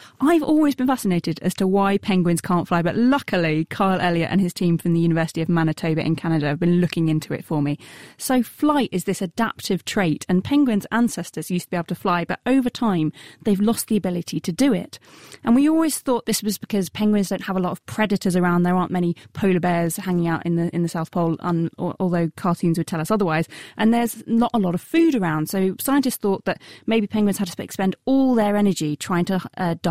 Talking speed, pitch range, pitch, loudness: 245 wpm, 170-220 Hz, 185 Hz, -21 LUFS